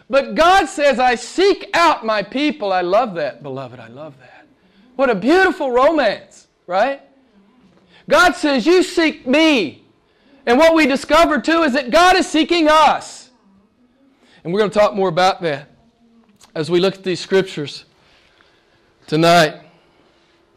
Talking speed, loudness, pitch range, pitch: 150 wpm, -15 LUFS, 190-305 Hz, 245 Hz